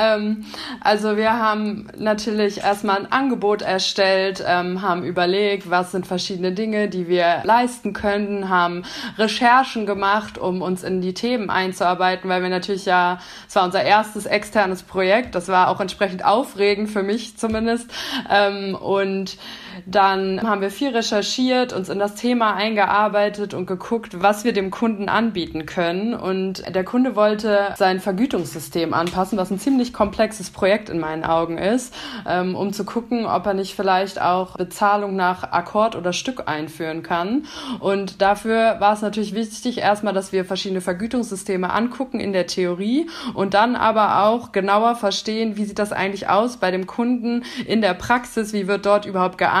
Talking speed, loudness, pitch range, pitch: 160 wpm, -20 LUFS, 185-220 Hz, 200 Hz